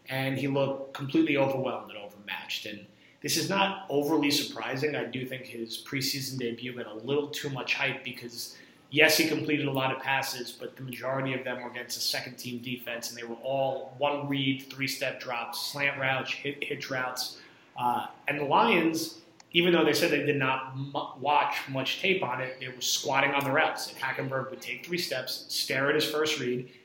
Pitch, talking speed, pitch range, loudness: 135 Hz, 205 wpm, 125-145 Hz, -29 LUFS